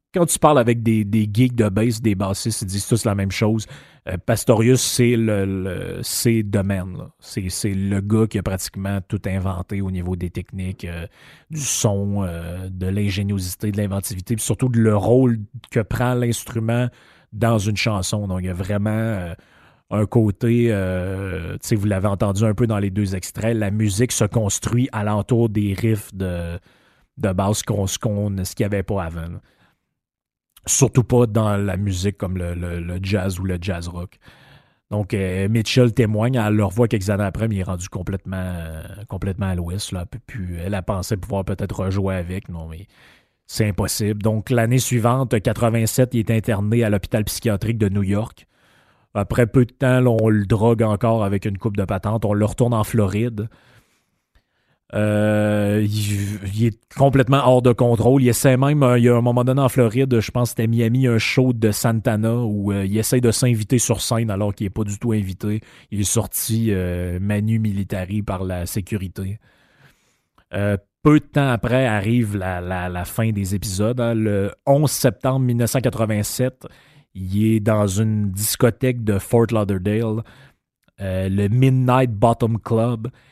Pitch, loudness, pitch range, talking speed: 105 Hz, -20 LUFS, 100-120 Hz, 185 wpm